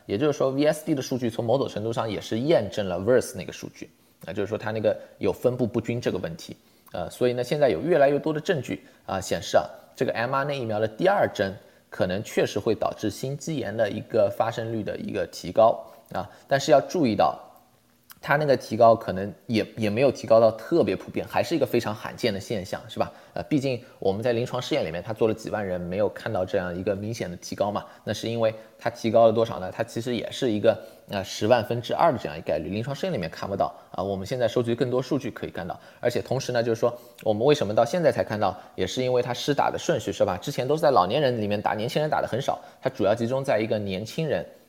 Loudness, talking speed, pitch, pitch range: -25 LUFS, 380 characters per minute, 120 Hz, 110-130 Hz